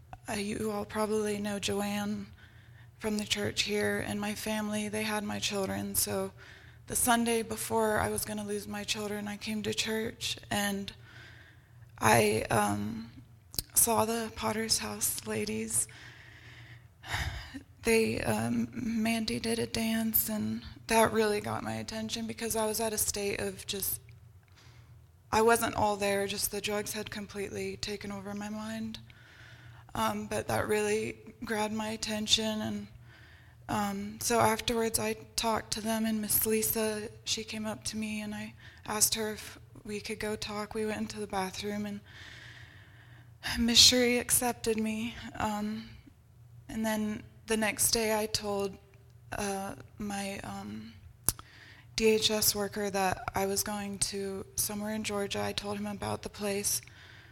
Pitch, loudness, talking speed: 200 Hz, -31 LUFS, 145 wpm